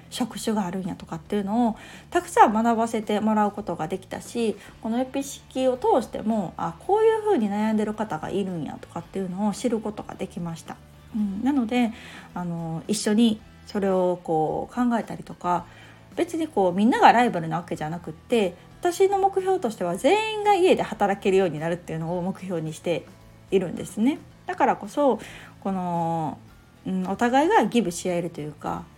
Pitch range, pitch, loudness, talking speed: 175-240 Hz, 205 Hz, -25 LUFS, 380 characters per minute